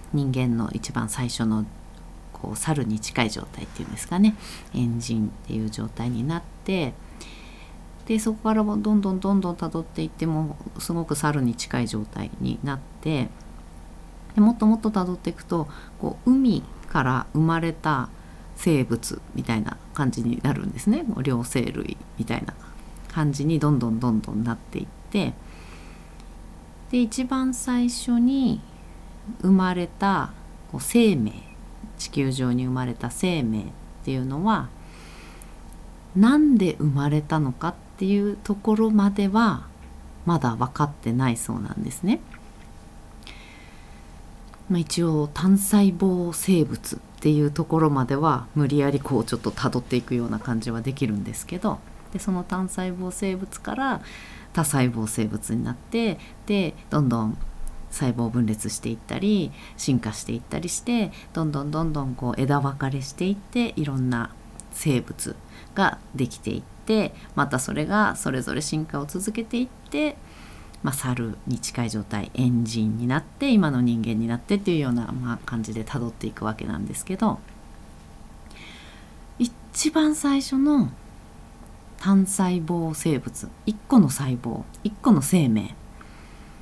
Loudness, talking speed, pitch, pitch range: -25 LUFS, 285 characters per minute, 140 Hz, 115-185 Hz